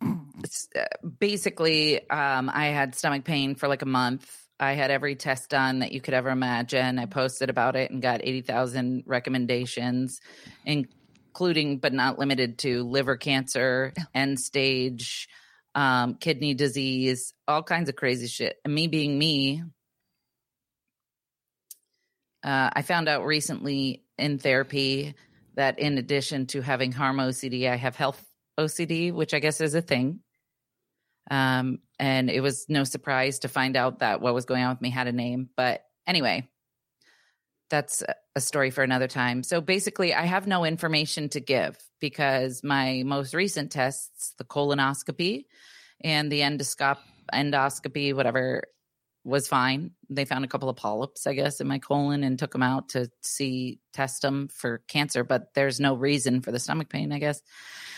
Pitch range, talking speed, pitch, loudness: 130-145 Hz, 160 wpm, 135 Hz, -26 LUFS